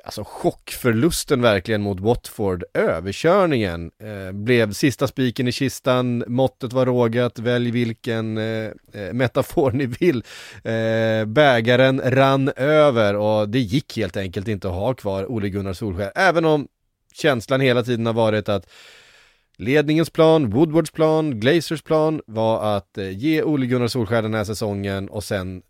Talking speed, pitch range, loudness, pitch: 140 wpm, 105-135 Hz, -20 LUFS, 120 Hz